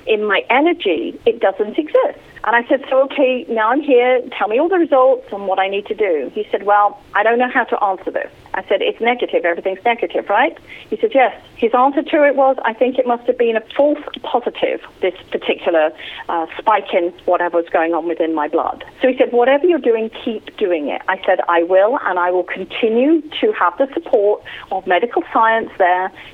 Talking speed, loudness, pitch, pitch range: 220 wpm, -16 LUFS, 240 Hz, 195-290 Hz